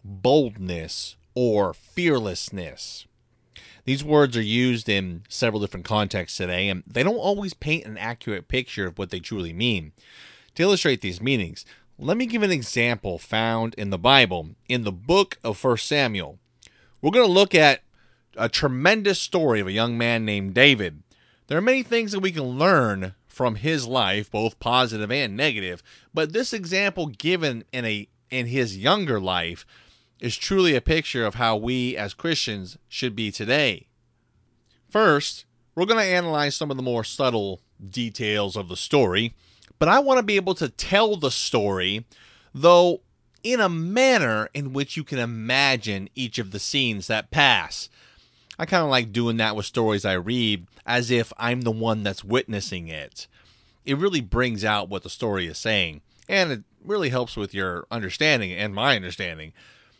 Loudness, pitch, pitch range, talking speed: -23 LUFS, 120 Hz, 105-145 Hz, 170 wpm